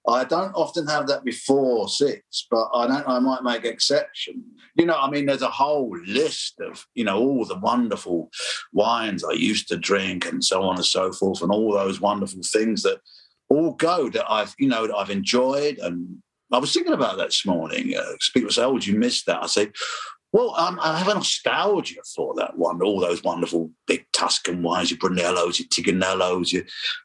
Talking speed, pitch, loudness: 200 wpm, 135 Hz, -22 LUFS